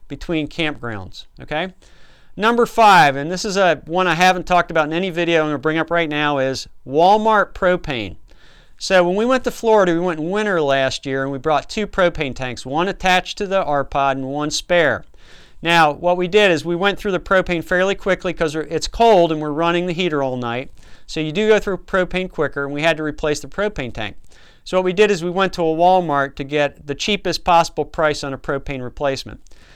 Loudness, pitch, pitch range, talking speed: -18 LUFS, 165 Hz, 140-185 Hz, 220 wpm